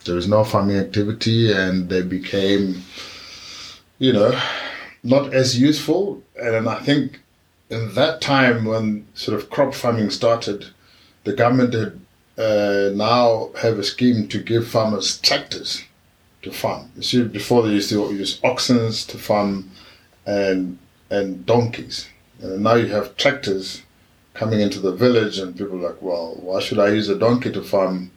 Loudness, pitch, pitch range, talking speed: -20 LUFS, 105 Hz, 100-120 Hz, 160 wpm